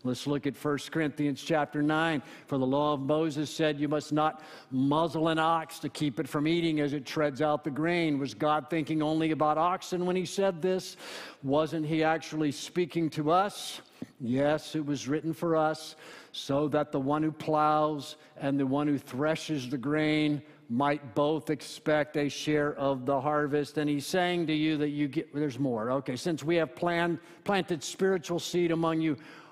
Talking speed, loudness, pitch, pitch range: 190 wpm, -30 LUFS, 155 Hz, 145-160 Hz